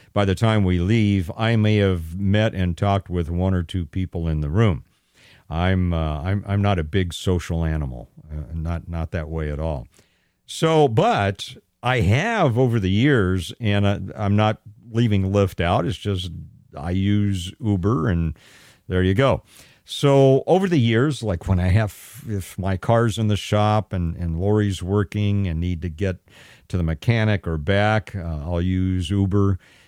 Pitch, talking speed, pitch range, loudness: 100 Hz, 180 wpm, 90-110 Hz, -21 LUFS